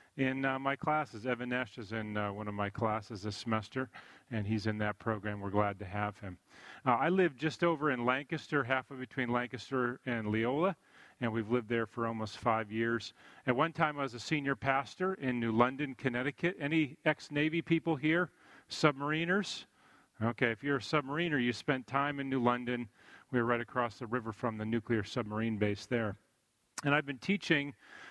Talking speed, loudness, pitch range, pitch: 190 wpm, -34 LUFS, 115-145 Hz, 125 Hz